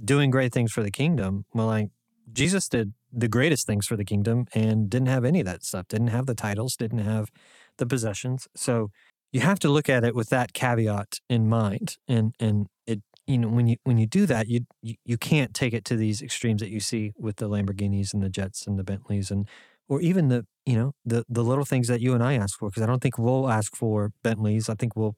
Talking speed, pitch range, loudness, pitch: 245 wpm, 105-125 Hz, -26 LUFS, 115 Hz